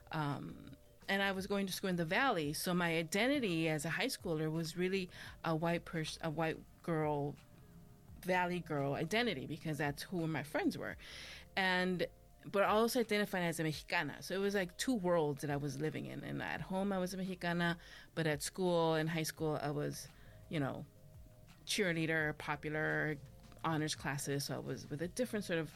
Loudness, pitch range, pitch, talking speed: -37 LUFS, 150-185 Hz, 165 Hz, 190 wpm